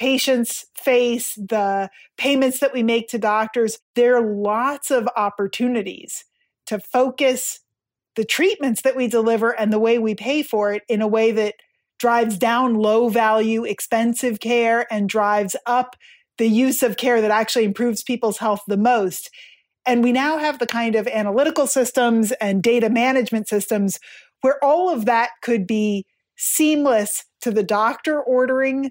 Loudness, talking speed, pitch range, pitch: -19 LUFS, 160 wpm, 215-255 Hz, 235 Hz